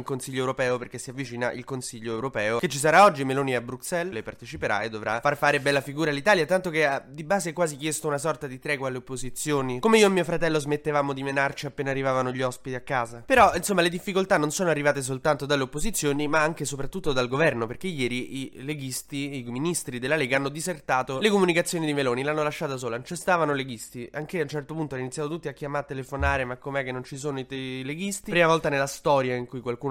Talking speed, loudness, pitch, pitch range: 235 wpm, -26 LUFS, 140 Hz, 130-155 Hz